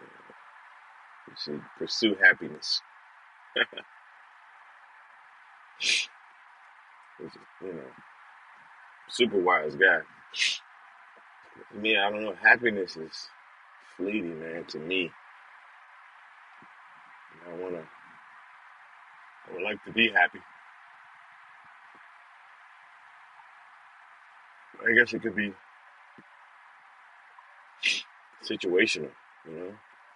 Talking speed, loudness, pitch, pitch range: 70 wpm, -27 LUFS, 100 Hz, 85-110 Hz